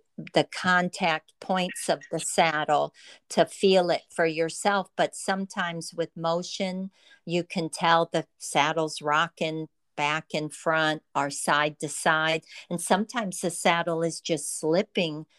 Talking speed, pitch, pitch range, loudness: 135 wpm, 165 Hz, 155-185 Hz, -26 LUFS